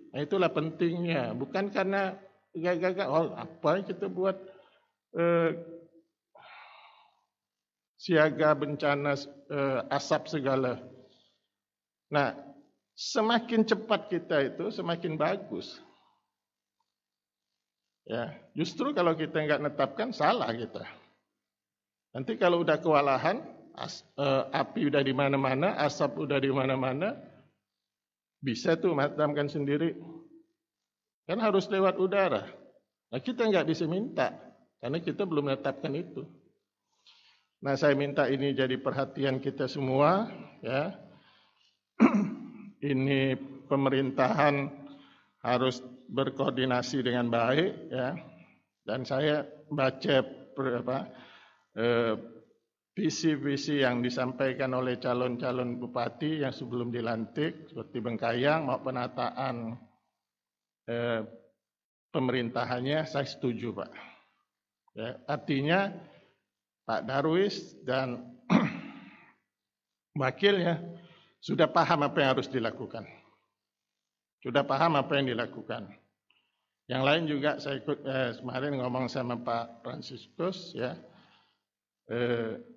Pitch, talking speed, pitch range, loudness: 140 Hz, 95 wpm, 130-170 Hz, -30 LUFS